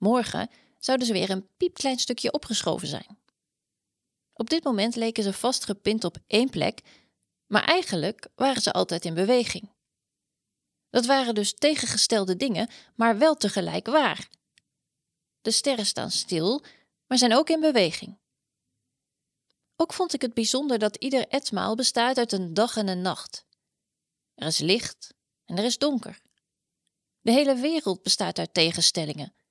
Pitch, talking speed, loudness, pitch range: 230 Hz, 145 wpm, -25 LUFS, 200-265 Hz